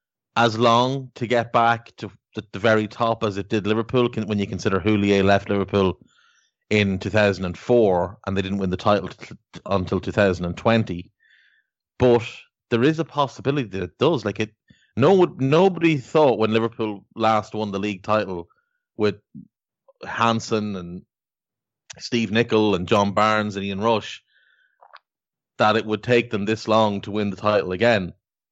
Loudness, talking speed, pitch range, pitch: -21 LUFS, 160 wpm, 100-120 Hz, 110 Hz